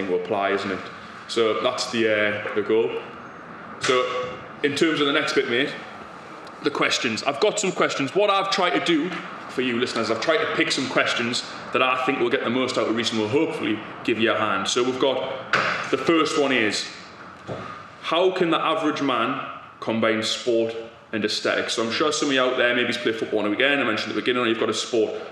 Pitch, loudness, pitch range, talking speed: 125 Hz, -22 LUFS, 115-160 Hz, 225 wpm